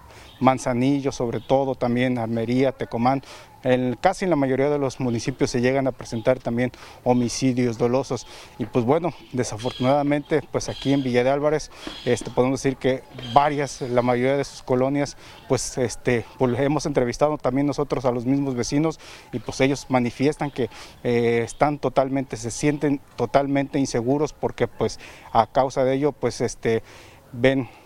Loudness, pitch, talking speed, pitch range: -23 LUFS, 130 Hz, 155 wpm, 125-140 Hz